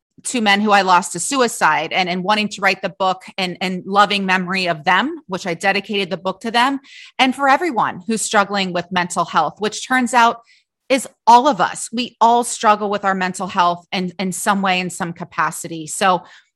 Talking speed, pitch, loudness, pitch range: 210 wpm, 195 Hz, -17 LUFS, 185-225 Hz